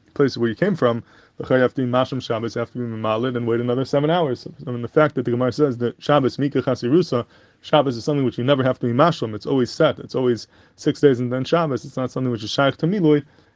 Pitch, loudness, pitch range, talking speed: 130 Hz, -21 LUFS, 120-145 Hz, 265 wpm